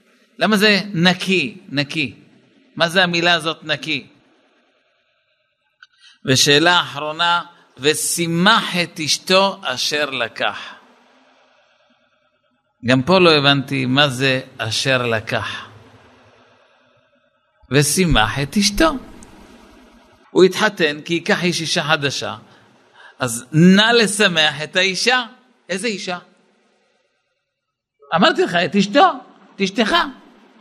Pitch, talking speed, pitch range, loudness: 175 Hz, 90 wpm, 145-205 Hz, -16 LUFS